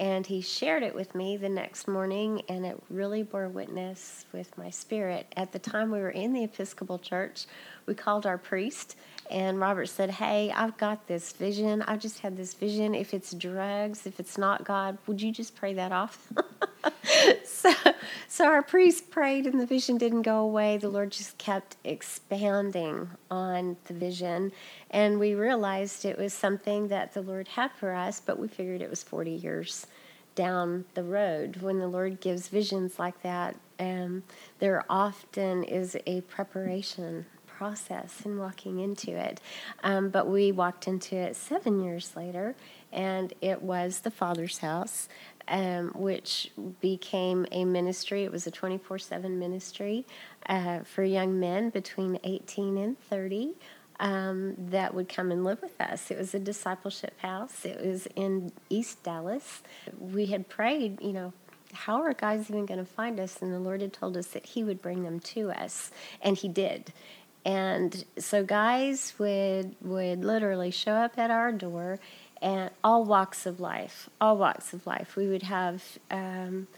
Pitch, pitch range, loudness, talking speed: 195 Hz, 185-210 Hz, -30 LUFS, 170 wpm